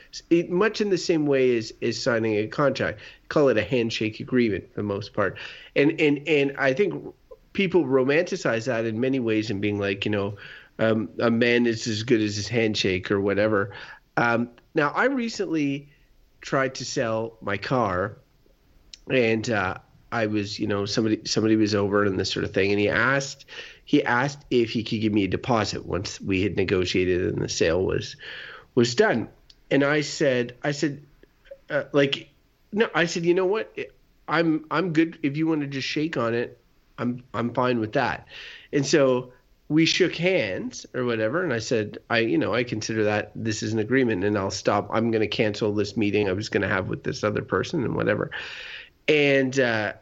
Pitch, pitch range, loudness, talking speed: 120 Hz, 110-145 Hz, -24 LUFS, 195 wpm